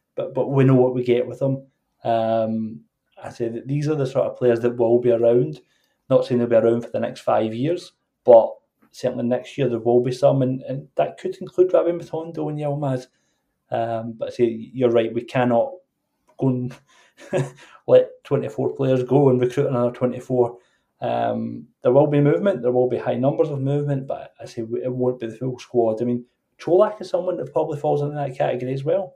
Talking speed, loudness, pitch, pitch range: 210 wpm, -21 LUFS, 130 Hz, 120-145 Hz